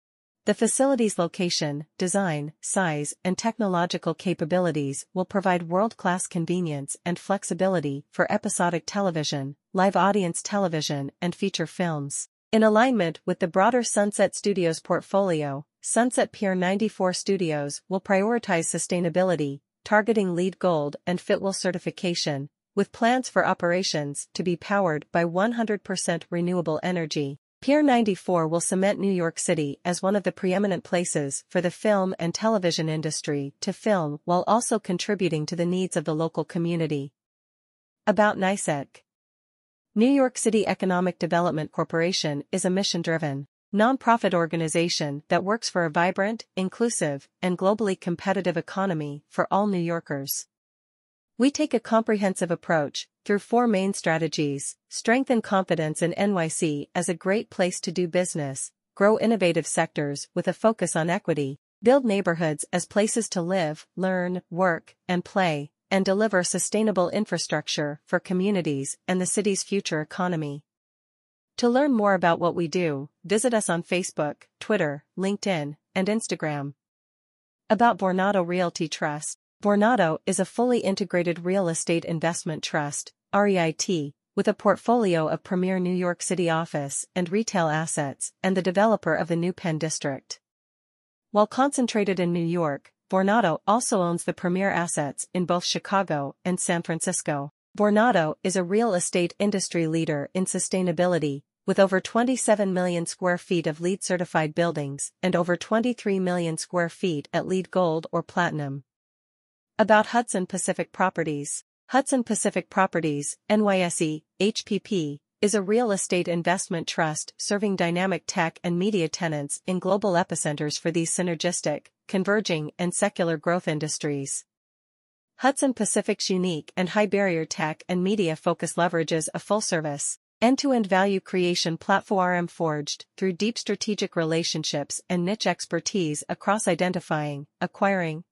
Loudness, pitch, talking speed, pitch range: -25 LUFS, 180 Hz, 140 wpm, 165-200 Hz